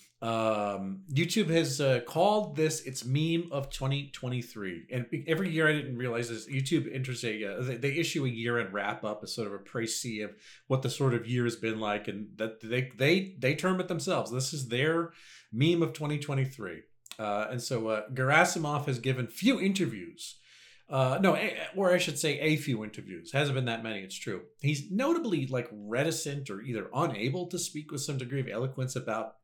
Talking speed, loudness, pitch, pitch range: 190 wpm, -31 LUFS, 130 Hz, 115-155 Hz